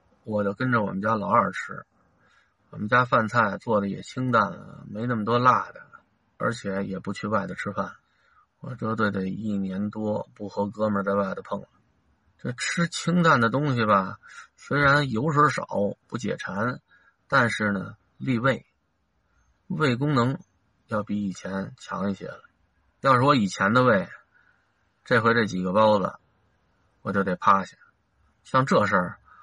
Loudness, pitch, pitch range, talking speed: -25 LUFS, 105 Hz, 100-125 Hz, 215 characters per minute